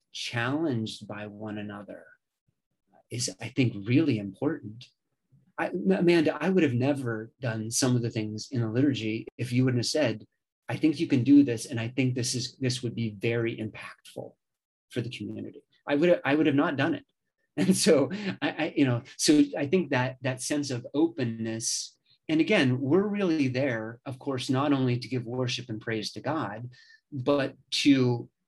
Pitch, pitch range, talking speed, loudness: 130 Hz, 115-145 Hz, 190 wpm, -27 LUFS